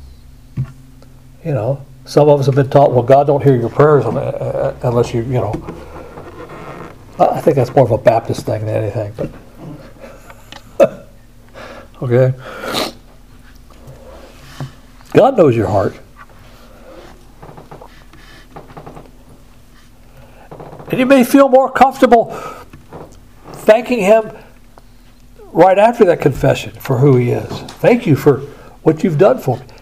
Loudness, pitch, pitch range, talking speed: -13 LUFS, 135 Hz, 125-170 Hz, 115 wpm